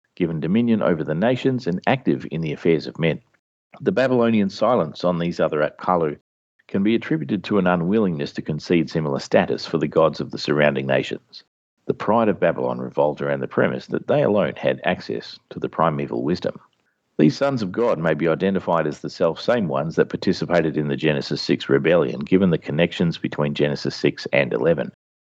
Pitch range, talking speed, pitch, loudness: 75-100 Hz, 185 wpm, 80 Hz, -21 LUFS